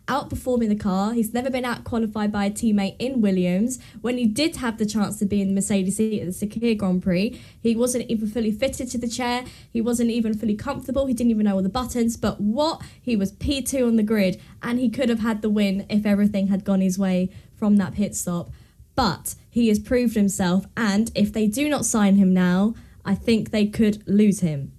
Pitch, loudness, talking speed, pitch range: 215 Hz, -23 LUFS, 225 wpm, 200-235 Hz